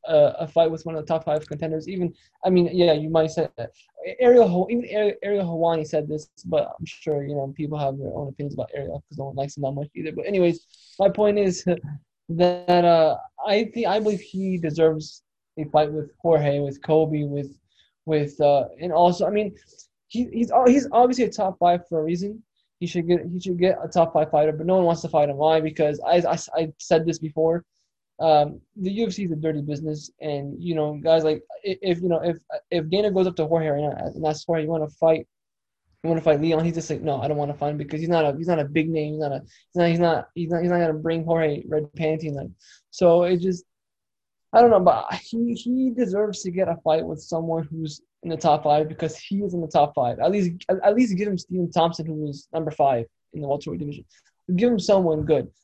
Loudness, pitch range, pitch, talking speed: -23 LUFS, 155-185 Hz, 165 Hz, 245 wpm